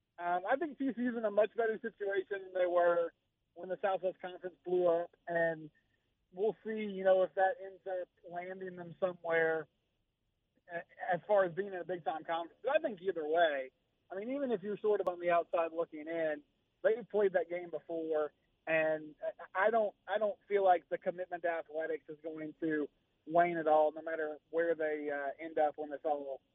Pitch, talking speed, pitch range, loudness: 175 Hz, 195 wpm, 155-190 Hz, -35 LUFS